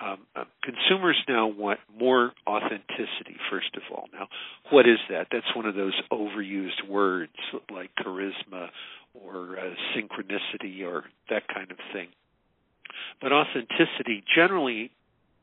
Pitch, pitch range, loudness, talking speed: 100 Hz, 95-110 Hz, -26 LUFS, 125 wpm